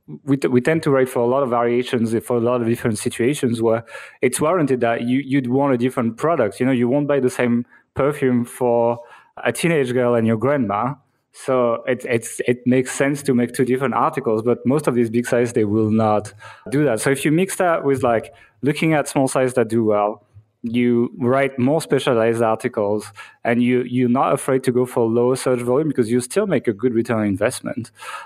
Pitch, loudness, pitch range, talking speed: 125 Hz, -19 LUFS, 115-135 Hz, 215 wpm